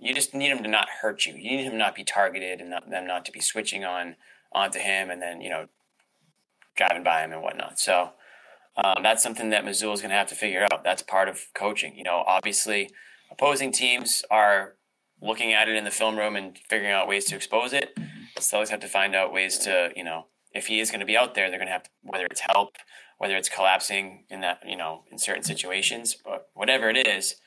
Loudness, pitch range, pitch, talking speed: -25 LUFS, 95-110 Hz, 100 Hz, 240 wpm